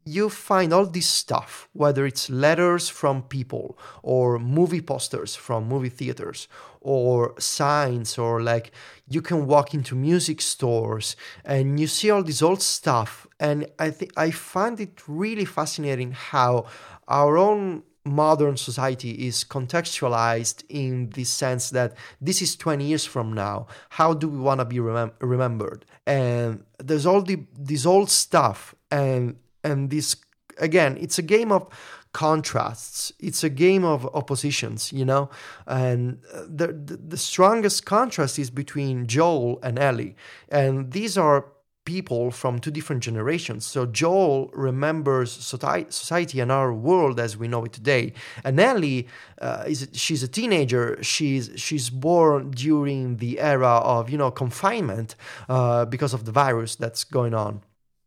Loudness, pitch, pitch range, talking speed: -23 LUFS, 140 Hz, 125-160 Hz, 150 wpm